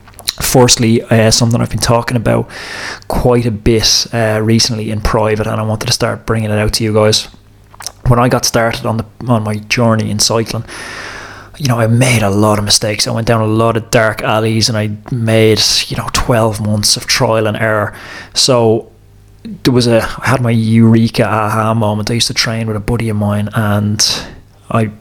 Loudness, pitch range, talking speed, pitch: -12 LUFS, 105-120 Hz, 200 wpm, 110 Hz